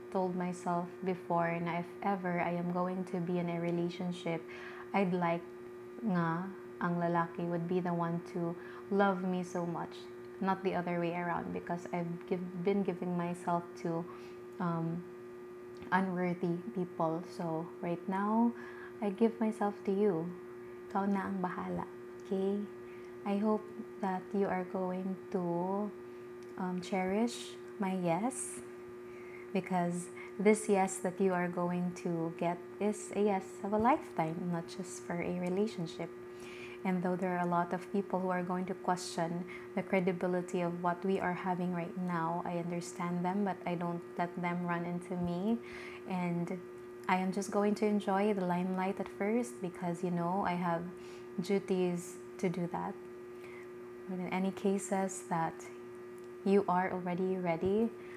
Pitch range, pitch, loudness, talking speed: 170-190 Hz, 180 Hz, -35 LUFS, 155 wpm